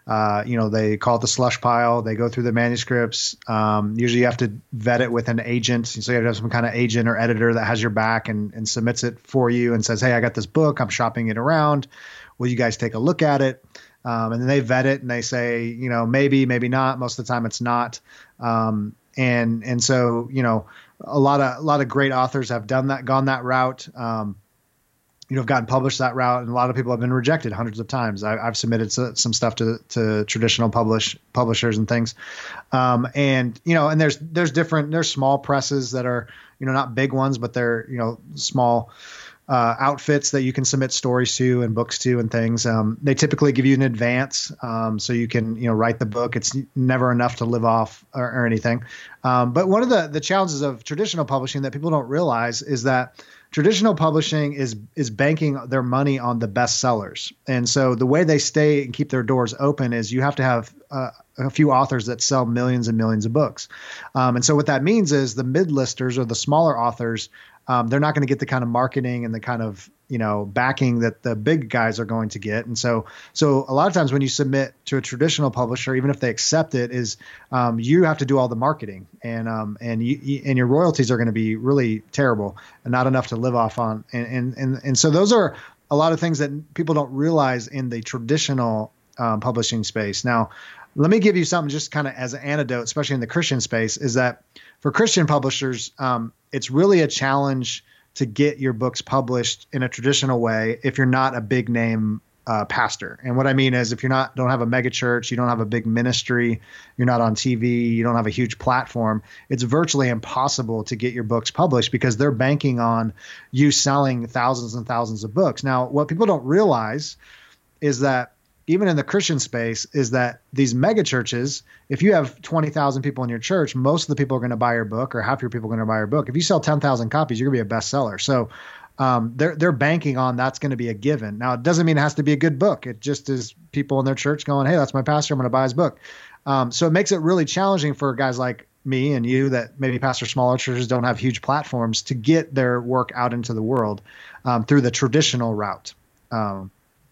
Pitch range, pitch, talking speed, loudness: 115-140 Hz, 125 Hz, 235 wpm, -21 LUFS